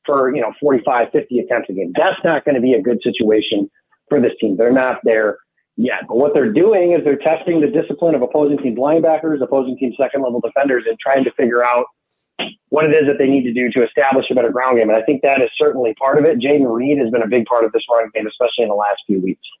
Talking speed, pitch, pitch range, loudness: 255 wpm, 135 Hz, 120-155 Hz, -16 LUFS